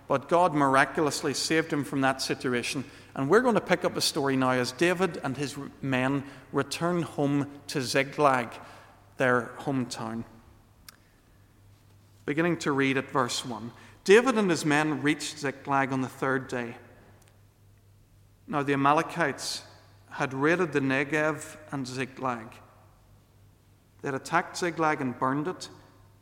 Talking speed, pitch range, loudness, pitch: 135 wpm, 110-150 Hz, -27 LUFS, 135 Hz